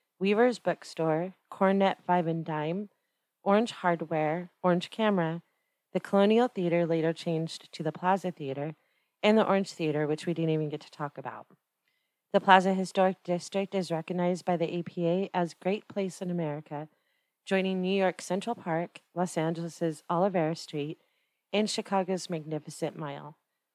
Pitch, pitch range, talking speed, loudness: 175 Hz, 160-195 Hz, 145 wpm, -29 LUFS